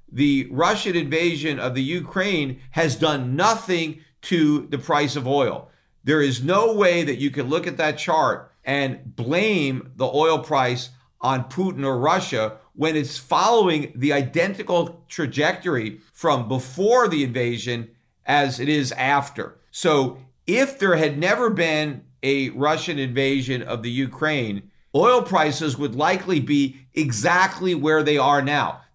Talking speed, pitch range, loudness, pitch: 145 wpm, 135-170 Hz, -21 LUFS, 145 Hz